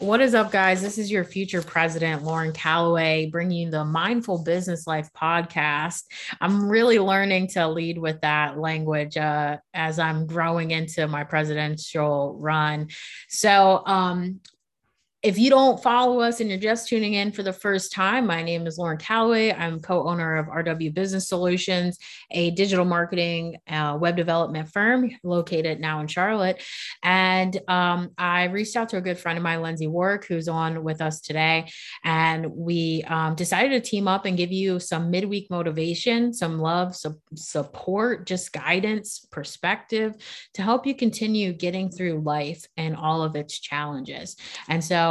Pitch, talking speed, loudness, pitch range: 170 Hz, 170 wpm, -23 LUFS, 160-195 Hz